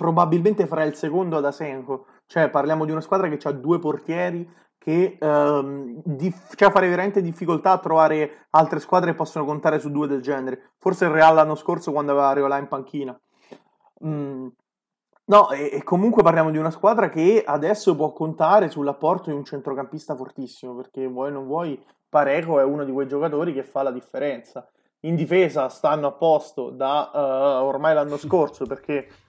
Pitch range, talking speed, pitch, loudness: 140-170 Hz, 180 wpm, 155 Hz, -21 LUFS